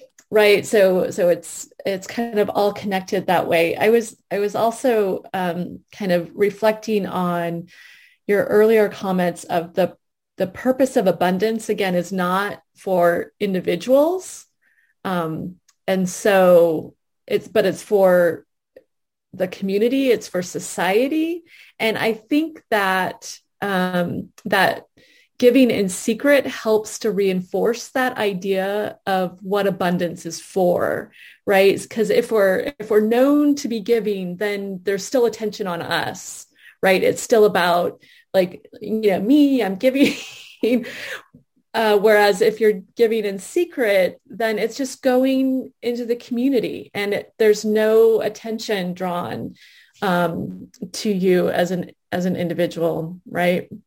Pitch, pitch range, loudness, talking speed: 205 Hz, 185-230 Hz, -20 LUFS, 135 wpm